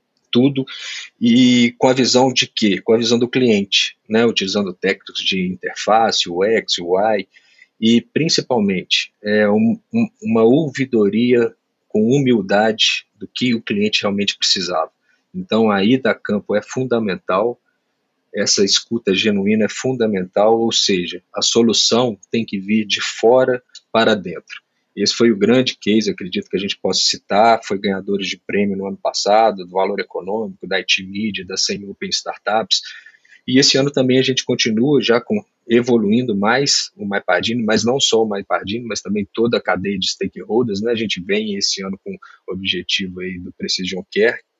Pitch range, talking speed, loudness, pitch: 100-130 Hz, 165 wpm, -17 LUFS, 115 Hz